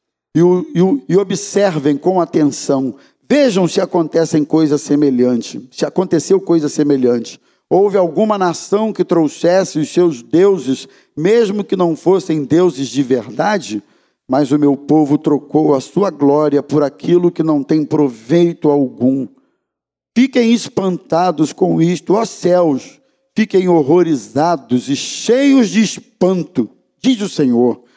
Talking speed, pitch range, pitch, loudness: 125 wpm, 145-190 Hz, 165 Hz, -14 LUFS